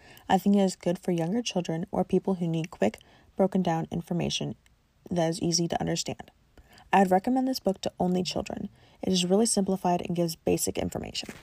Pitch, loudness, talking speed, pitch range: 180 Hz, -28 LUFS, 195 wpm, 170-195 Hz